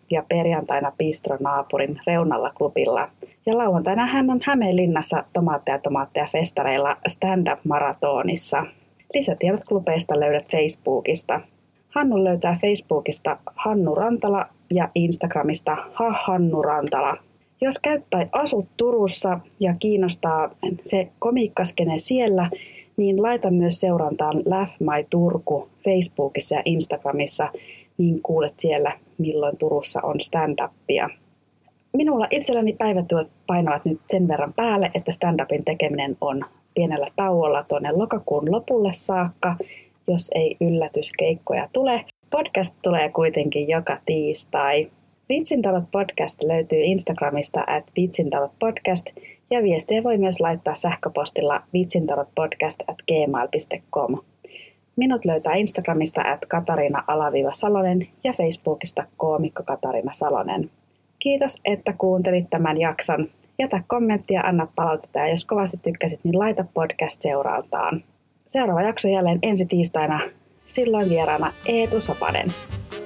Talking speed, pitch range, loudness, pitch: 110 wpm, 155-205 Hz, -22 LUFS, 175 Hz